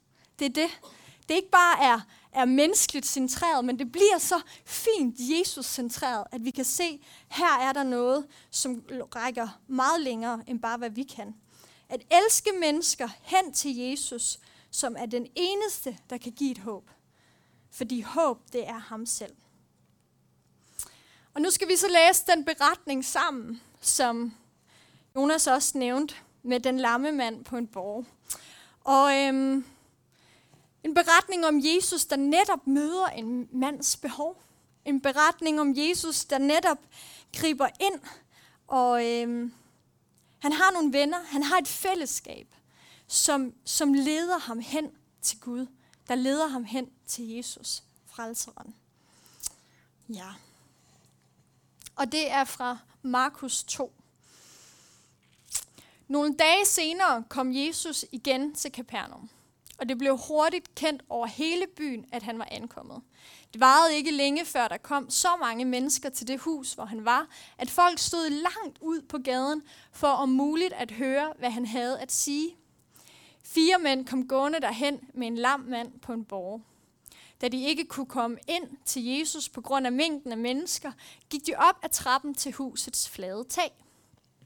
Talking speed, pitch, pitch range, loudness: 155 wpm, 275 Hz, 245-315 Hz, -27 LUFS